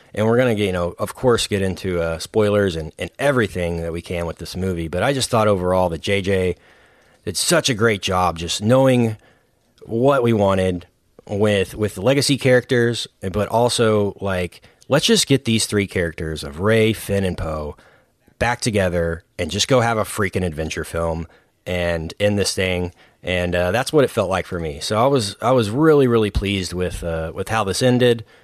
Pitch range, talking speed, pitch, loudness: 90-115 Hz, 195 wpm, 100 Hz, -19 LUFS